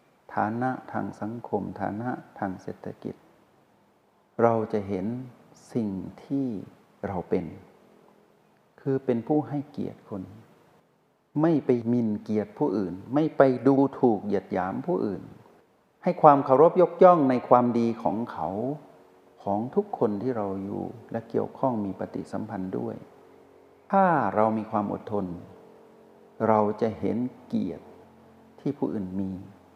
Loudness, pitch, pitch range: -26 LUFS, 115 Hz, 105-140 Hz